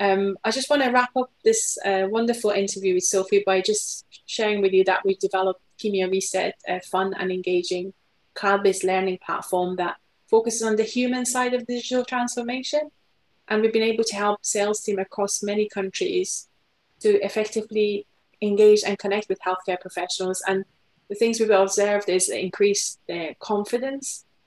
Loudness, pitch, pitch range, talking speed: -23 LUFS, 205 Hz, 190-225 Hz, 165 wpm